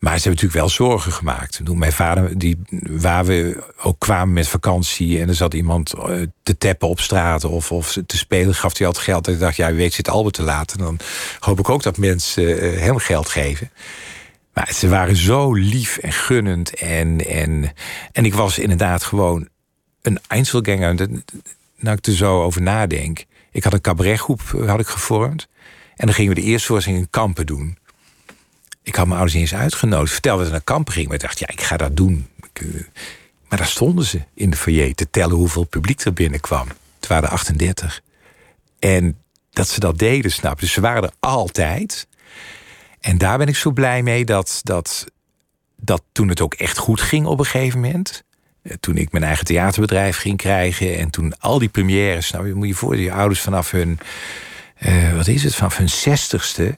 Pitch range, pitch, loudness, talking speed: 85-105 Hz, 95 Hz, -18 LUFS, 200 wpm